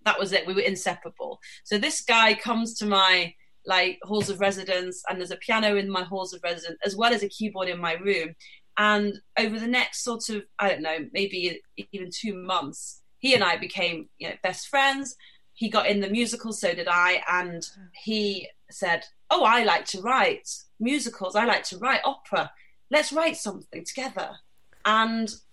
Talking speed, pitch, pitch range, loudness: 190 wpm, 200 Hz, 185-225 Hz, -25 LUFS